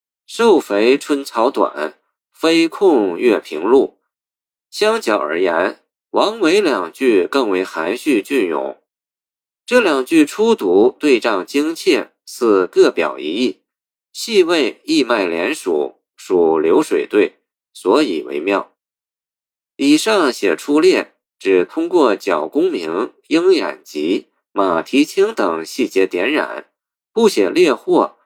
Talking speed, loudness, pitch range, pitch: 165 characters per minute, -16 LUFS, 320-395 Hz, 370 Hz